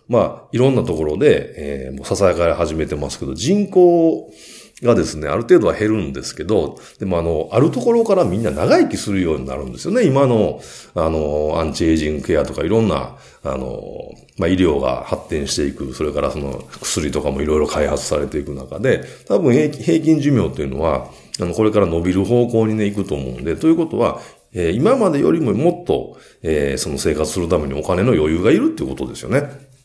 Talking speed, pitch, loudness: 410 characters per minute, 100 Hz, -18 LUFS